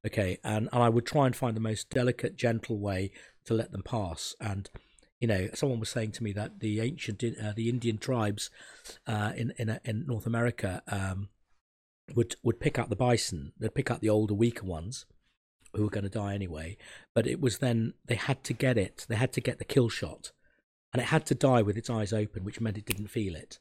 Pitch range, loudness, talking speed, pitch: 105-120 Hz, -31 LUFS, 230 wpm, 110 Hz